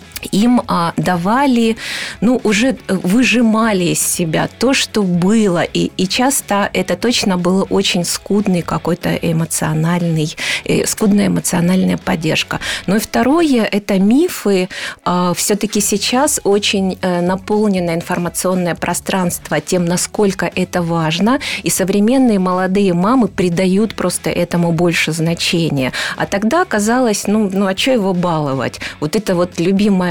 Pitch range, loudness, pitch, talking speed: 175-215 Hz, -15 LUFS, 190 Hz, 125 wpm